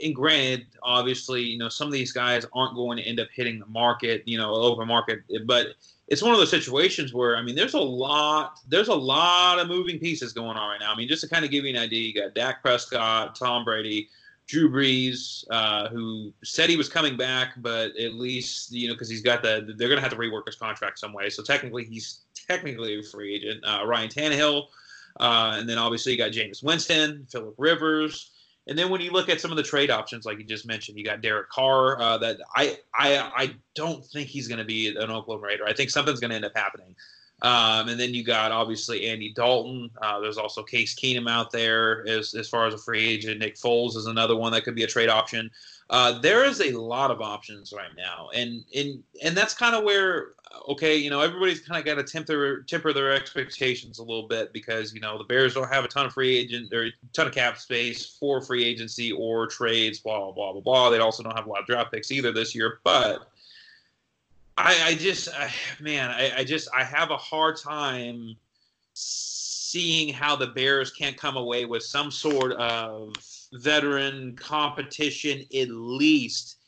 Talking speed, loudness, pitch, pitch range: 220 wpm, -24 LUFS, 120 Hz, 115-140 Hz